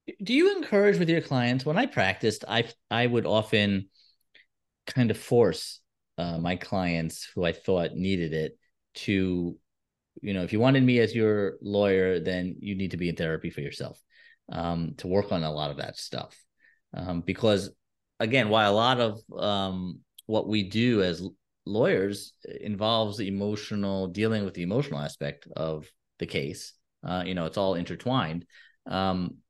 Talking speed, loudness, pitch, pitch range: 170 wpm, -27 LUFS, 100 Hz, 90-110 Hz